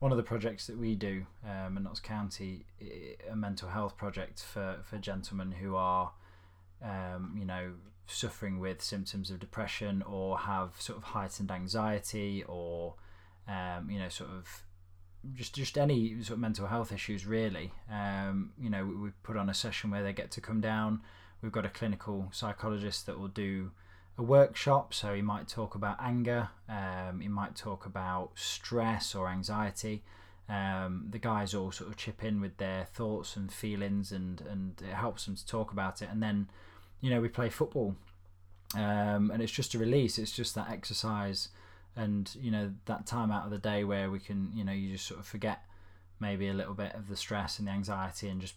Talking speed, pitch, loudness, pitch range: 195 wpm, 100 Hz, -36 LUFS, 95-110 Hz